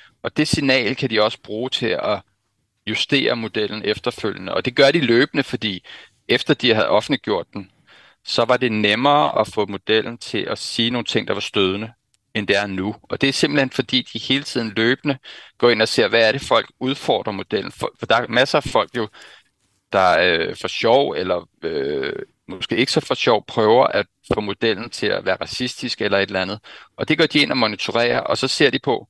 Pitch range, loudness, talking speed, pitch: 105-135 Hz, -19 LUFS, 210 wpm, 120 Hz